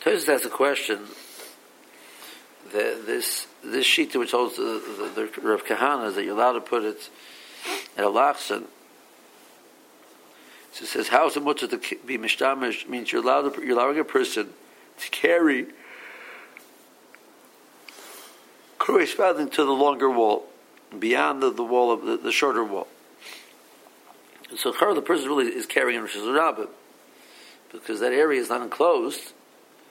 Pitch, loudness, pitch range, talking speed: 380 Hz, -24 LUFS, 340-420 Hz, 140 wpm